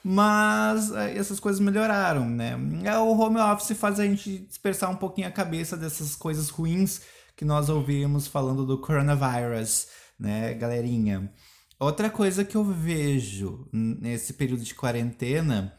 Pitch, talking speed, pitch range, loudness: 145 Hz, 135 wpm, 120-195 Hz, -26 LUFS